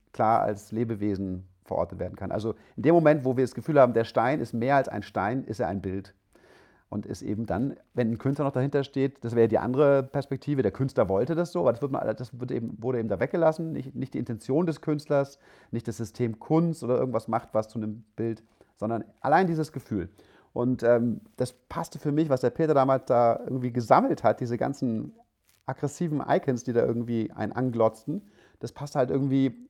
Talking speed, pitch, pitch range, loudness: 210 wpm, 125 Hz, 115-140 Hz, -27 LUFS